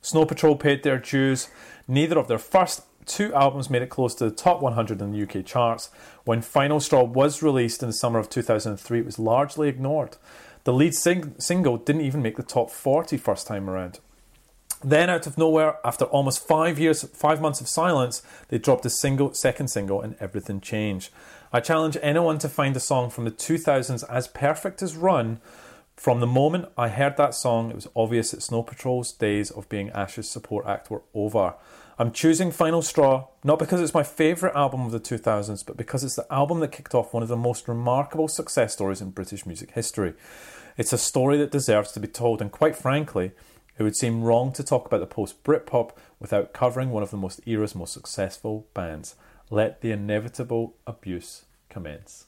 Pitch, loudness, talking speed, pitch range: 125 Hz, -24 LUFS, 200 wpm, 110-150 Hz